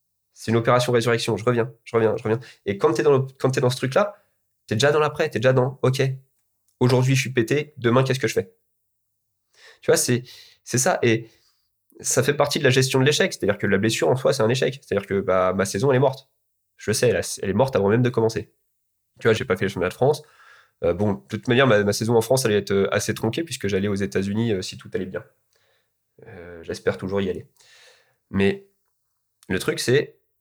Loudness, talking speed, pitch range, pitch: -22 LUFS, 235 wpm, 105-130 Hz, 115 Hz